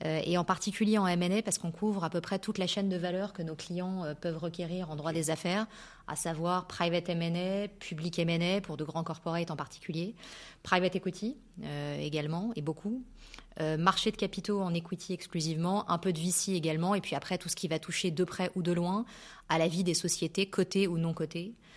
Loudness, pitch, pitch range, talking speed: -33 LUFS, 180 Hz, 165-195 Hz, 205 wpm